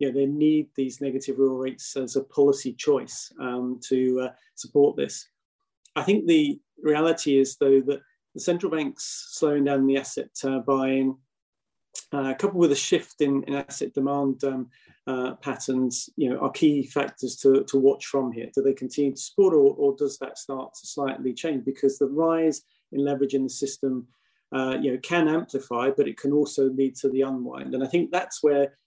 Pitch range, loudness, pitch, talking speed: 135-150 Hz, -25 LUFS, 135 Hz, 195 wpm